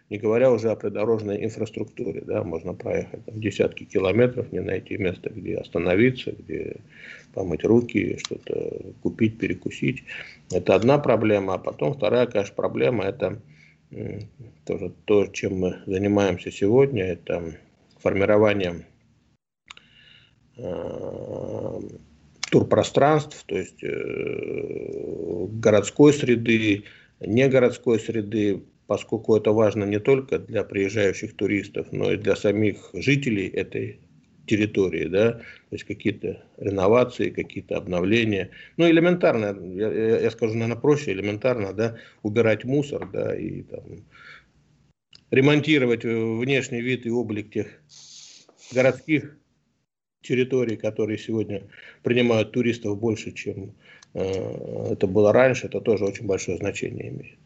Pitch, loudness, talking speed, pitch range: 115 Hz, -24 LUFS, 110 wpm, 105-130 Hz